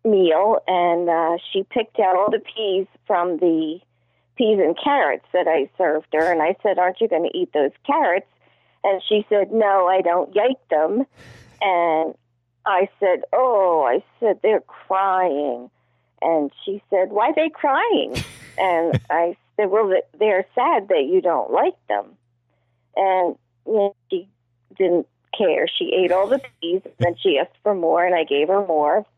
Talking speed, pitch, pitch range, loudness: 170 wpm, 185 Hz, 155-210 Hz, -20 LUFS